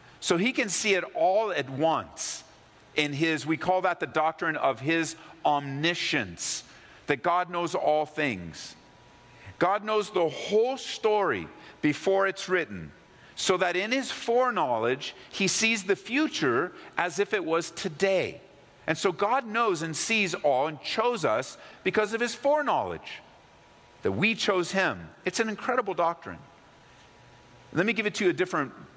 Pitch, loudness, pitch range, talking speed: 185 Hz, -27 LUFS, 160-215 Hz, 155 wpm